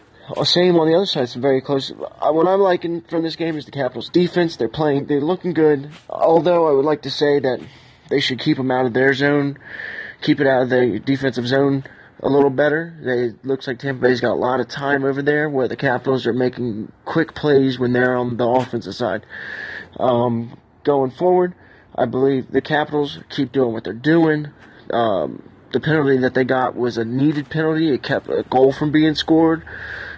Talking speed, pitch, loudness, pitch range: 205 wpm, 140 Hz, -19 LUFS, 130-155 Hz